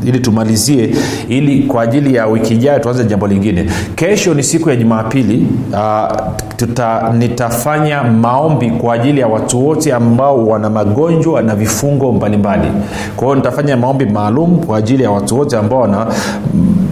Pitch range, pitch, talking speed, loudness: 110-140 Hz, 120 Hz, 155 wpm, -12 LUFS